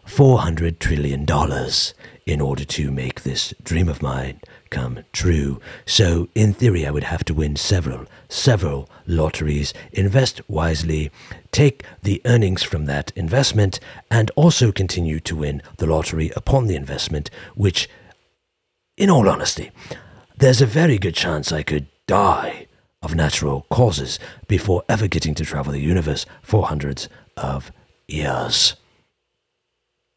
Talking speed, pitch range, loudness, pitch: 135 wpm, 75-105 Hz, -20 LUFS, 85 Hz